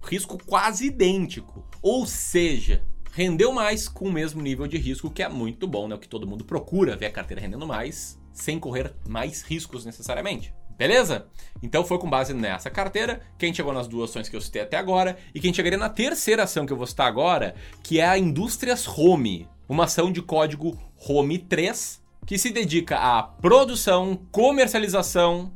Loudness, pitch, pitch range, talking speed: -24 LUFS, 170 Hz, 125-190 Hz, 180 wpm